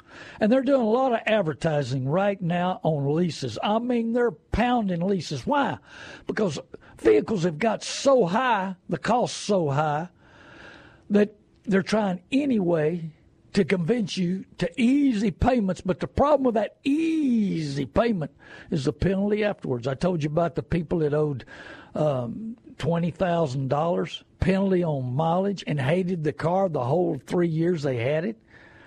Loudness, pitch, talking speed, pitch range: -25 LUFS, 185 Hz, 155 wpm, 155-220 Hz